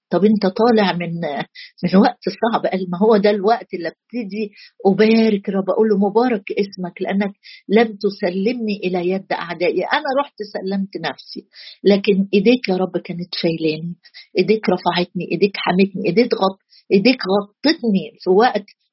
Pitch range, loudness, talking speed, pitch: 185-220 Hz, -18 LUFS, 145 wpm, 200 Hz